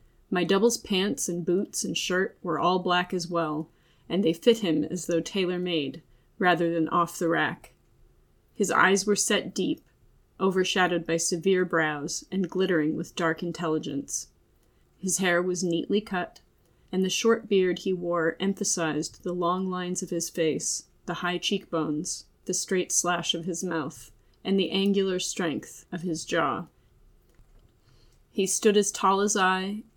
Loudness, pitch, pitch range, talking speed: -27 LUFS, 180 Hz, 165-190 Hz, 160 wpm